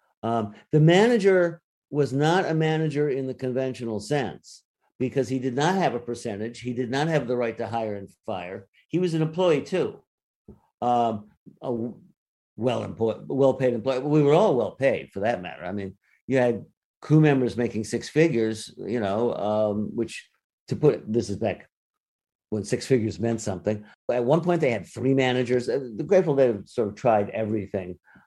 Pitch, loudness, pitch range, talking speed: 125 Hz, -25 LUFS, 110-145 Hz, 185 wpm